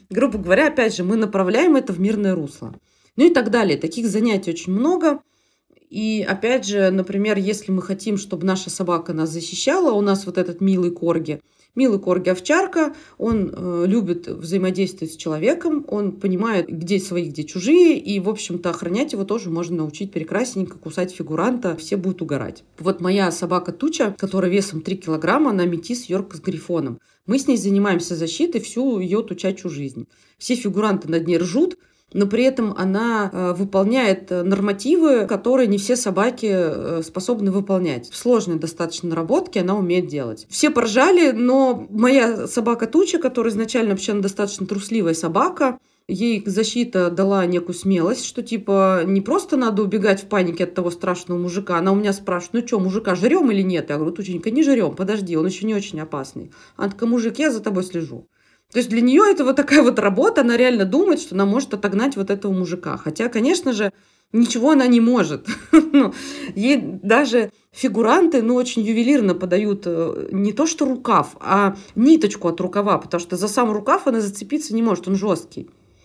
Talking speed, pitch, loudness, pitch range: 170 wpm, 200 Hz, -19 LUFS, 180-240 Hz